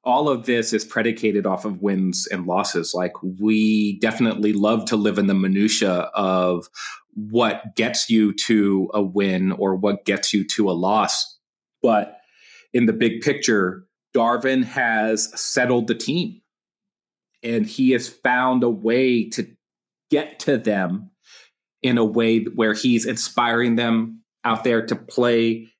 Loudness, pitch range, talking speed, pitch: -20 LUFS, 105-120 Hz, 150 wpm, 115 Hz